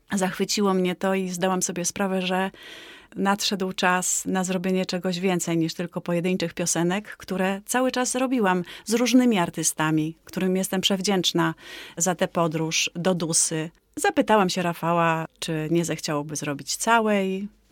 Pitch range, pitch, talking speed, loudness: 170-195 Hz, 185 Hz, 140 wpm, -24 LUFS